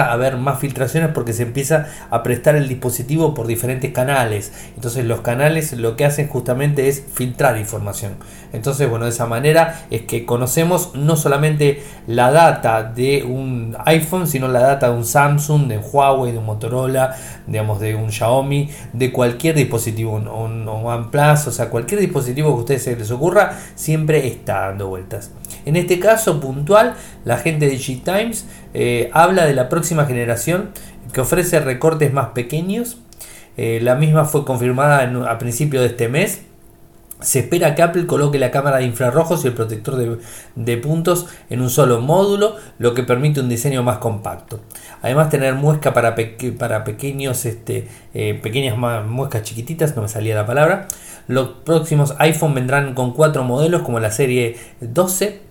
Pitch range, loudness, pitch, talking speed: 120-155 Hz, -17 LUFS, 130 Hz, 170 wpm